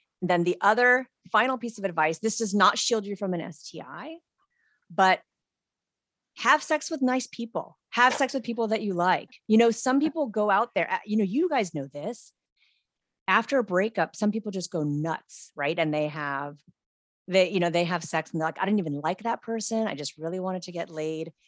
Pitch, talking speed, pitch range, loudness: 195 Hz, 210 wpm, 165-235 Hz, -26 LUFS